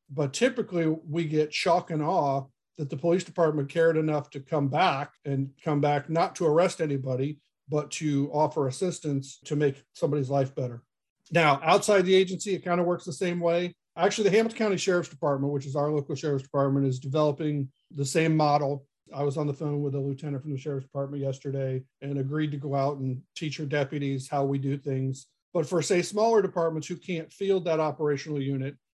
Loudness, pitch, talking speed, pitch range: -27 LUFS, 150 Hz, 200 wpm, 140-165 Hz